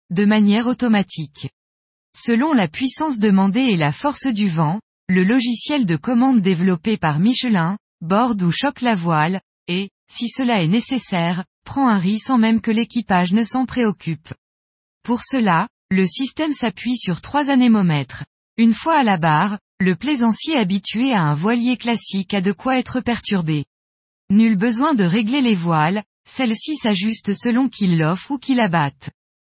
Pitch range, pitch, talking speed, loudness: 180-245 Hz, 215 Hz, 160 wpm, -19 LUFS